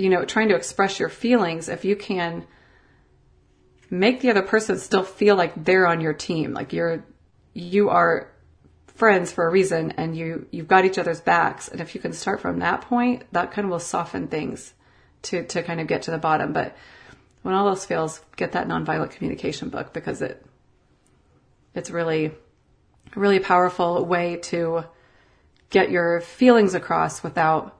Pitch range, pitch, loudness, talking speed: 160-195 Hz, 175 Hz, -22 LUFS, 175 wpm